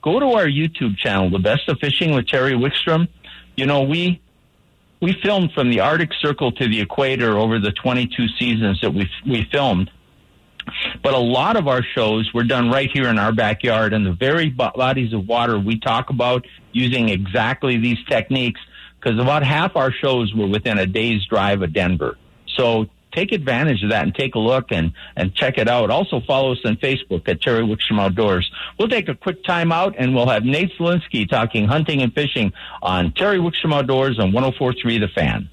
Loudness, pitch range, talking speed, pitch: -19 LUFS, 110-140 Hz, 200 wpm, 125 Hz